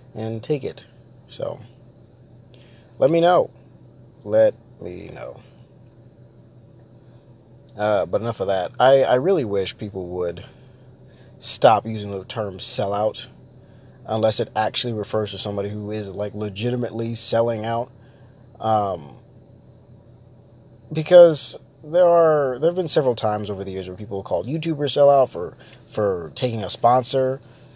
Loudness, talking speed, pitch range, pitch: -21 LUFS, 130 wpm, 110-130 Hz, 120 Hz